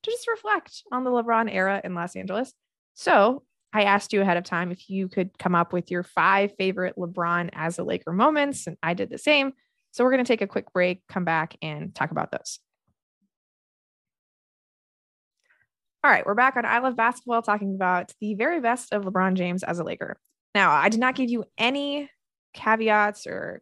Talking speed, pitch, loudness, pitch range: 200 wpm, 205 Hz, -24 LUFS, 180-245 Hz